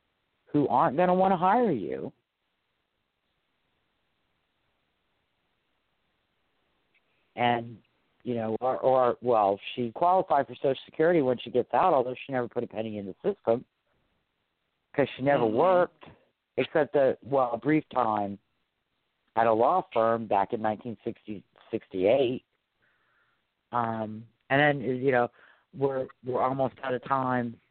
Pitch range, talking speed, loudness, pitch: 115-135 Hz, 135 wpm, -27 LUFS, 125 Hz